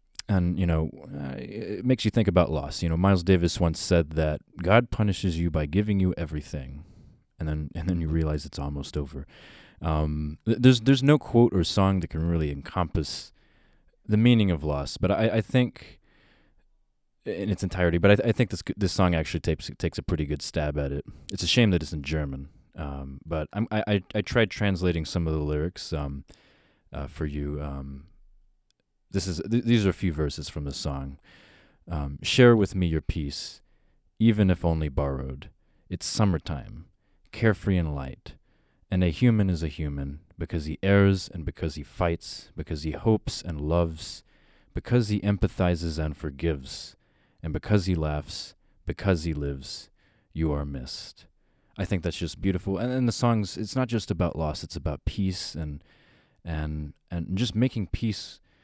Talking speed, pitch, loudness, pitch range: 180 wpm, 85 Hz, -27 LUFS, 75-100 Hz